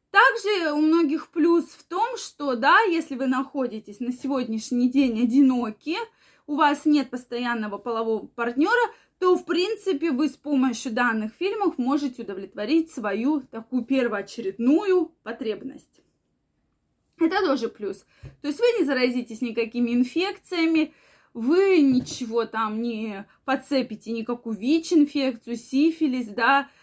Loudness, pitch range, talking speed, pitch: -24 LUFS, 235-320 Hz, 120 wpm, 270 Hz